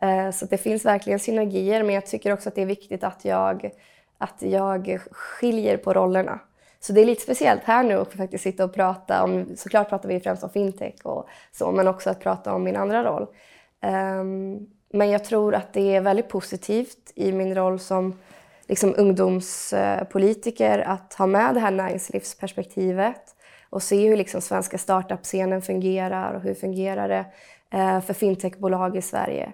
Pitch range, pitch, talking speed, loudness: 185-205 Hz, 190 Hz, 170 wpm, -23 LUFS